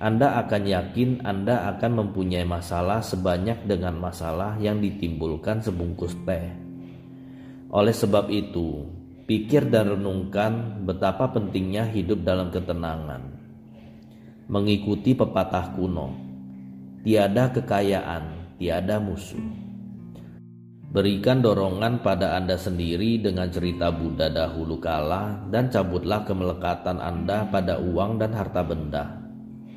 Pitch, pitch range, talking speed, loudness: 95 Hz, 85-110 Hz, 105 wpm, -25 LUFS